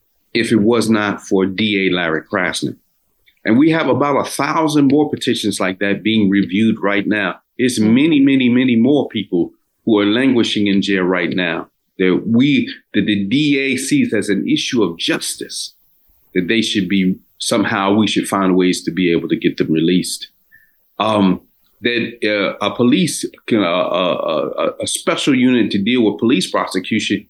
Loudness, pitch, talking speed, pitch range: -16 LUFS, 105 Hz, 170 wpm, 95-135 Hz